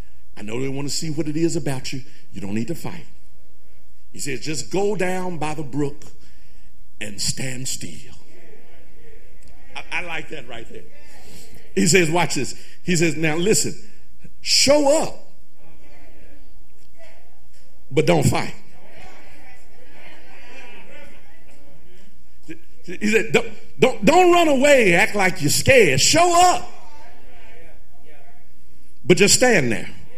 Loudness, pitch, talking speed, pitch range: -19 LUFS, 155 Hz, 125 wpm, 130-195 Hz